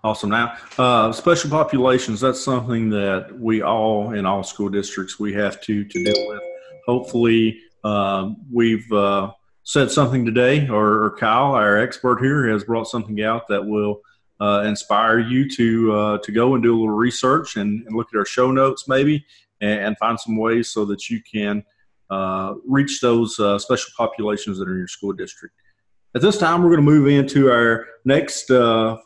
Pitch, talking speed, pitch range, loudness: 115 Hz, 185 wpm, 105-130 Hz, -19 LUFS